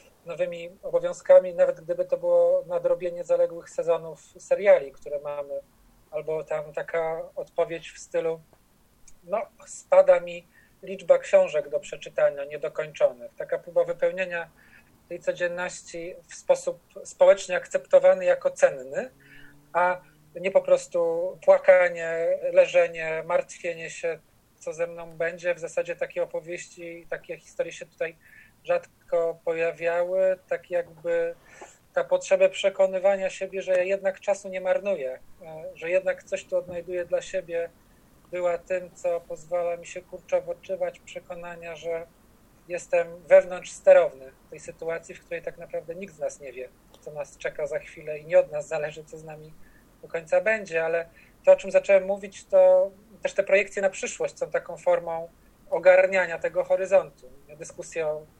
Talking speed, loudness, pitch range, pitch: 145 wpm, -25 LUFS, 170-280 Hz, 185 Hz